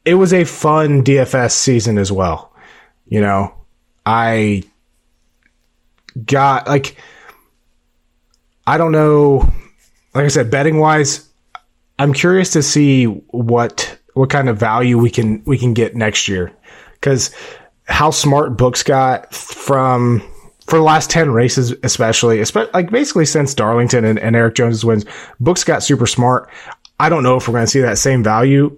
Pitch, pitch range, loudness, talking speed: 125 Hz, 110-145 Hz, -14 LUFS, 155 wpm